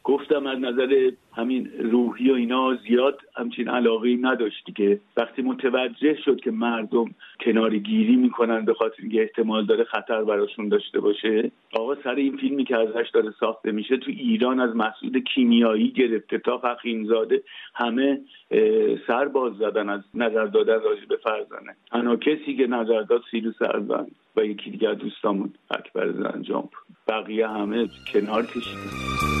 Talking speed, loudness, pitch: 150 wpm, -24 LUFS, 125 Hz